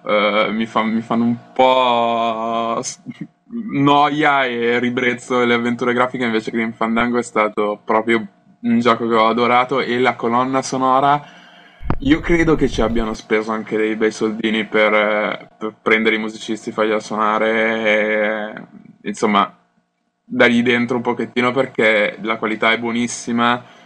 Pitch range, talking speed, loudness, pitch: 110-125 Hz, 145 wpm, -17 LUFS, 115 Hz